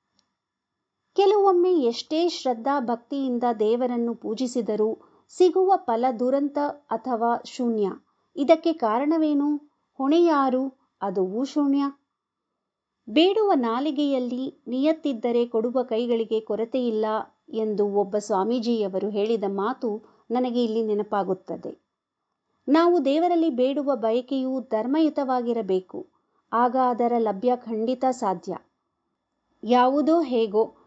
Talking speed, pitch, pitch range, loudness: 80 wpm, 250 Hz, 225-290 Hz, -24 LUFS